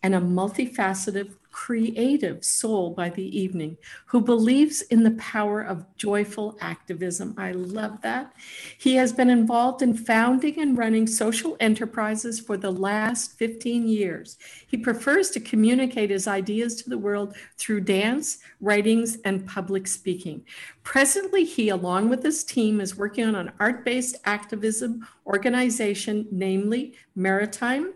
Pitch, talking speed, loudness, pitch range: 220 Hz, 140 wpm, -24 LUFS, 200-245 Hz